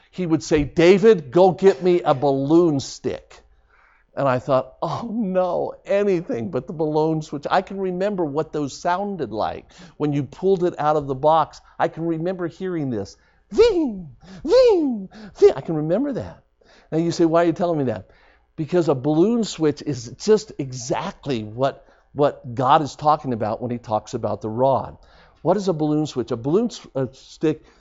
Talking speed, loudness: 180 wpm, -21 LUFS